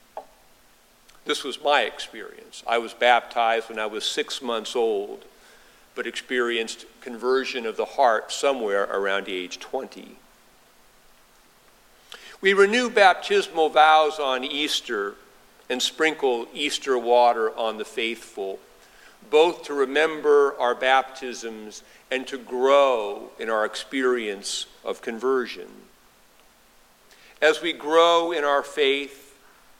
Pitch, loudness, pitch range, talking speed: 130 Hz, -23 LUFS, 115-155 Hz, 110 wpm